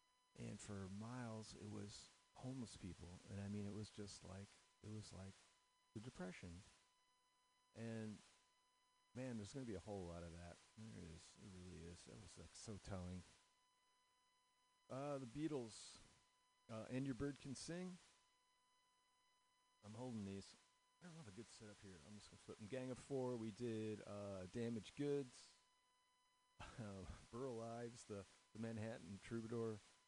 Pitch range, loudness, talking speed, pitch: 100-165 Hz, -53 LUFS, 160 wpm, 115 Hz